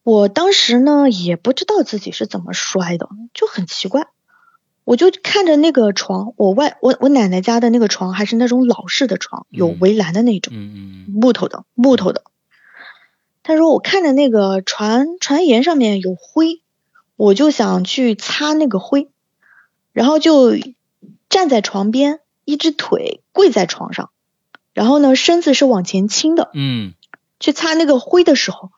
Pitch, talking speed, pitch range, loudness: 240 Hz, 230 characters per minute, 195-300 Hz, -14 LUFS